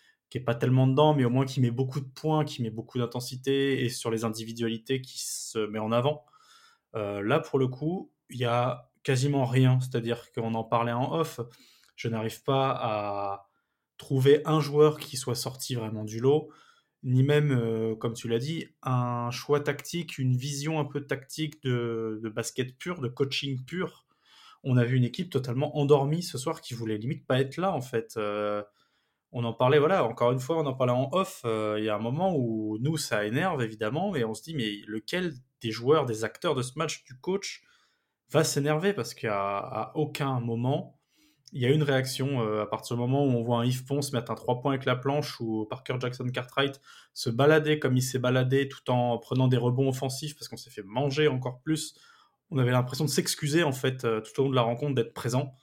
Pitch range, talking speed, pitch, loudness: 115-145 Hz, 220 wpm, 130 Hz, -28 LUFS